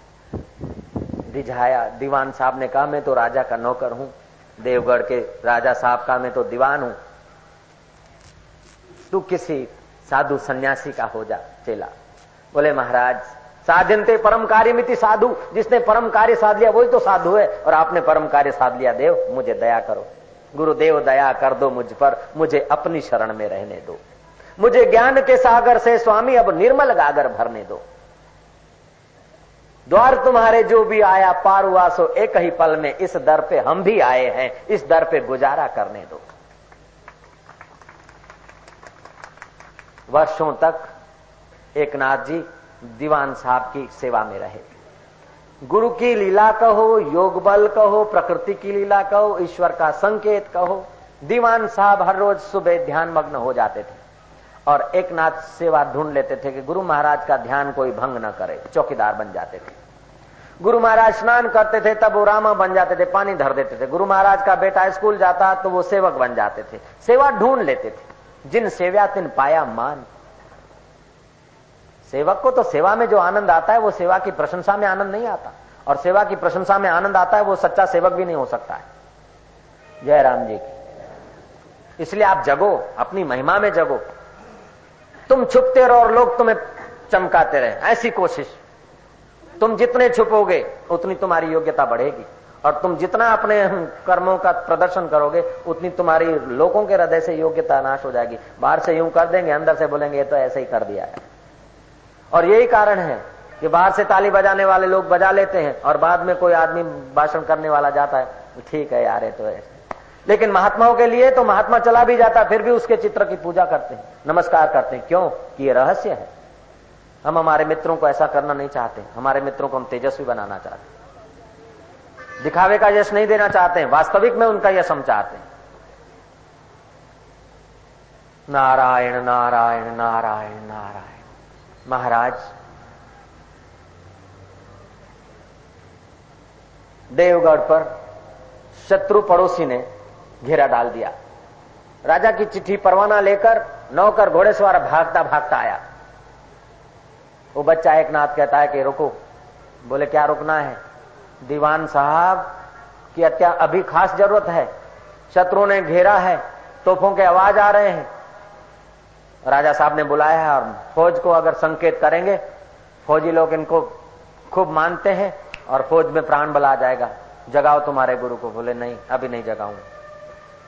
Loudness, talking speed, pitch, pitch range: -17 LUFS, 160 wpm, 170 Hz, 140-205 Hz